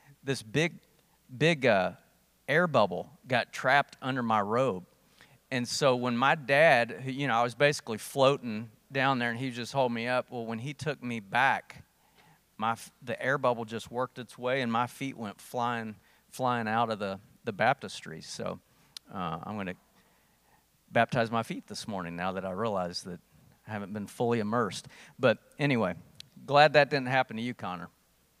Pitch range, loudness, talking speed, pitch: 115-135 Hz, -29 LUFS, 175 wpm, 125 Hz